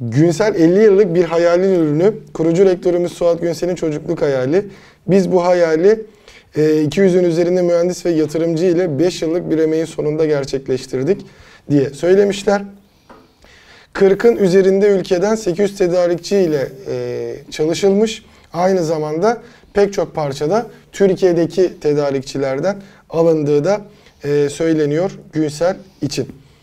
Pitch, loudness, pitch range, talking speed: 175 Hz, -16 LUFS, 155-195 Hz, 110 wpm